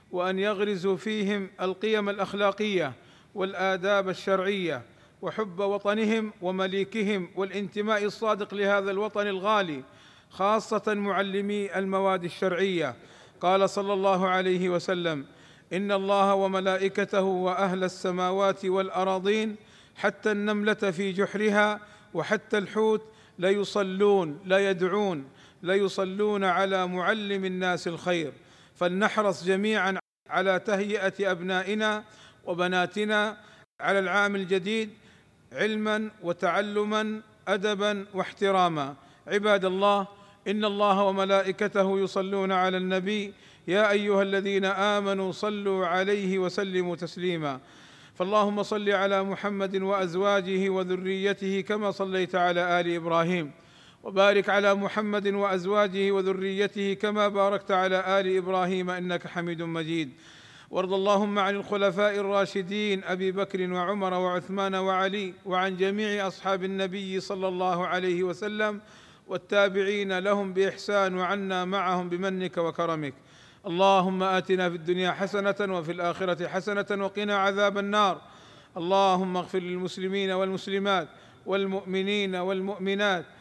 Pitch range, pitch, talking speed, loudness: 185-205 Hz, 195 Hz, 100 wpm, -27 LUFS